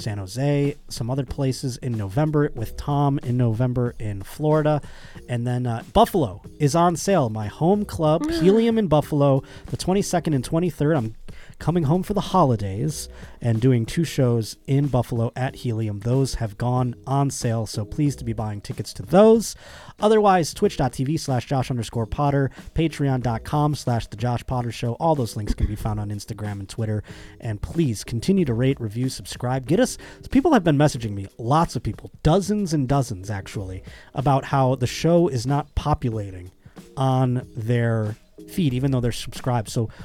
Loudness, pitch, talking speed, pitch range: -23 LUFS, 130 Hz, 170 wpm, 115-150 Hz